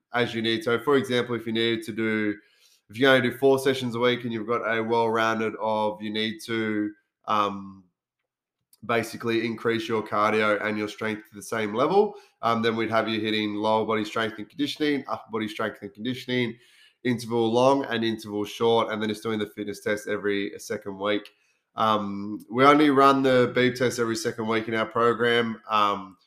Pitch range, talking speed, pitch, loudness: 105-120 Hz, 195 wpm, 115 Hz, -25 LUFS